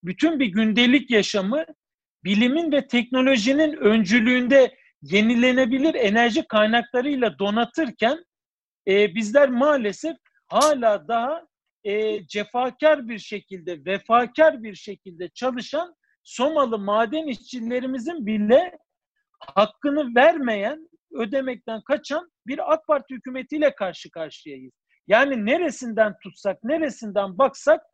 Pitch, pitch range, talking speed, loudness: 245 Hz, 215-295 Hz, 95 wpm, -21 LUFS